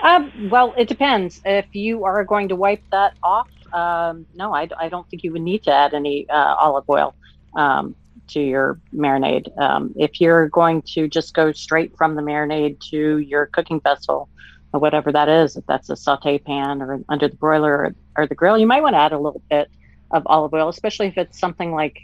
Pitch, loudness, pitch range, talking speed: 155 Hz, -19 LUFS, 145-185 Hz, 220 wpm